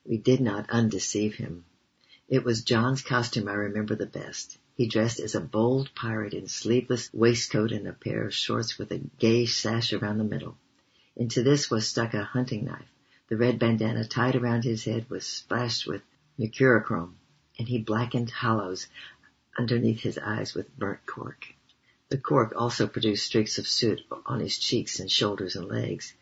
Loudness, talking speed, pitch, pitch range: -27 LUFS, 175 wpm, 115 Hz, 110-120 Hz